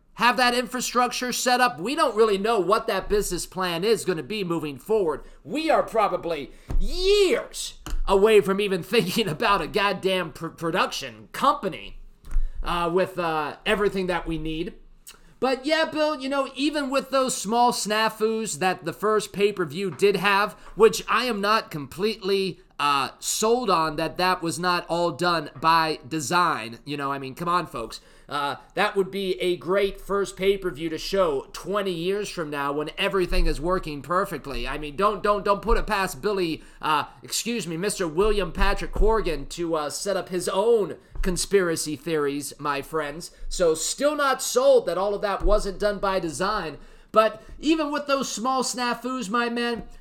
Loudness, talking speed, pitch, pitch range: -24 LUFS, 175 wpm, 195 Hz, 170-225 Hz